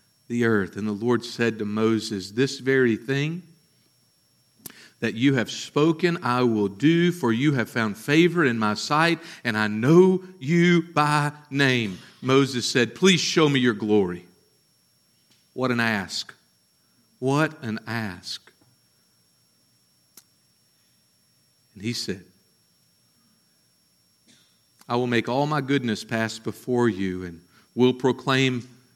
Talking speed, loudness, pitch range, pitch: 125 wpm, -23 LUFS, 105-140 Hz, 120 Hz